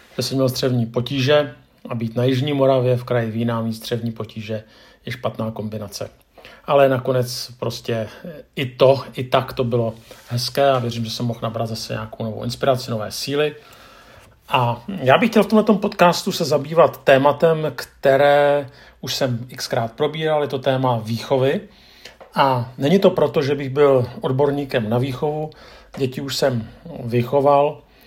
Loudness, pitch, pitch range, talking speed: -20 LUFS, 130 Hz, 120-145 Hz, 160 wpm